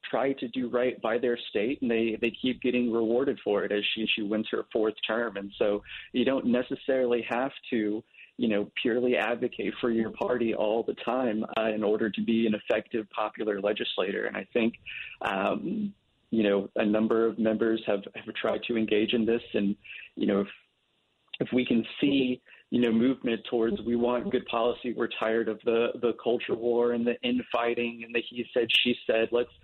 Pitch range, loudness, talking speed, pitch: 110-125 Hz, -28 LUFS, 200 wpm, 115 Hz